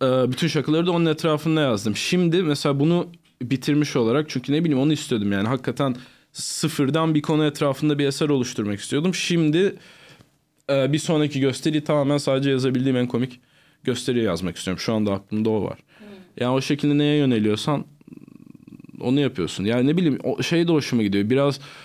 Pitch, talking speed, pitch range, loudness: 145 Hz, 160 wpm, 130-155 Hz, -22 LUFS